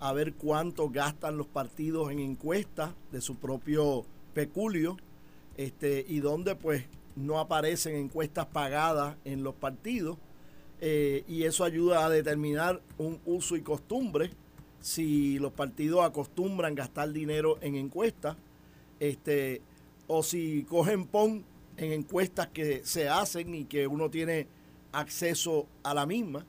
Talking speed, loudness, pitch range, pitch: 135 wpm, -32 LUFS, 145-165 Hz, 155 Hz